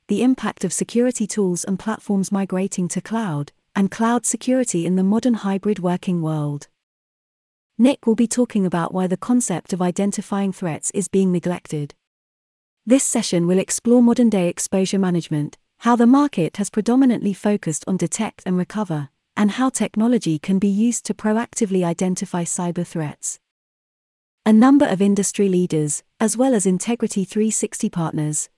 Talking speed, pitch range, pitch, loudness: 155 wpm, 175-225 Hz, 195 Hz, -20 LUFS